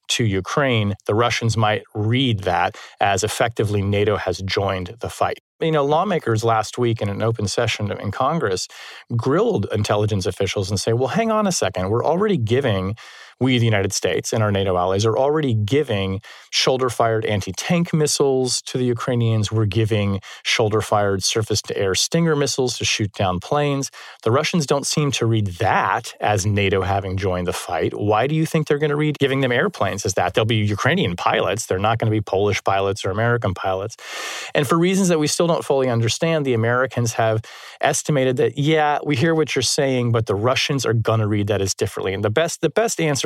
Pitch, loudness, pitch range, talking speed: 115 Hz, -20 LUFS, 105-140 Hz, 190 wpm